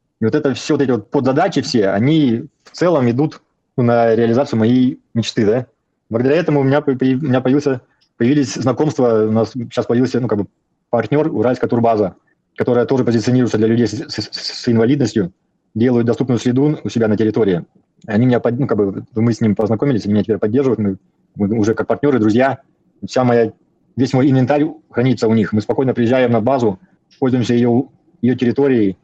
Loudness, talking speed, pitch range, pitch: -16 LUFS, 180 wpm, 110-135 Hz, 120 Hz